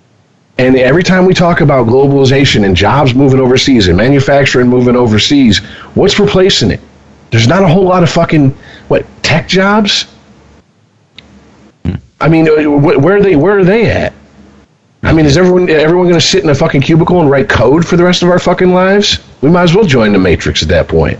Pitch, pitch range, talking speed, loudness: 150 Hz, 130-180 Hz, 195 wpm, -8 LUFS